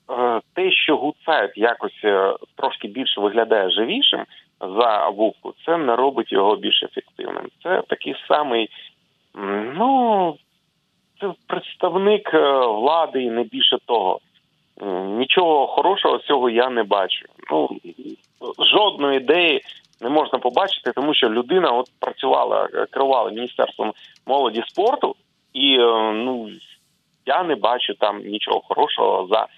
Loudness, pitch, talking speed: -19 LUFS, 155 Hz, 115 wpm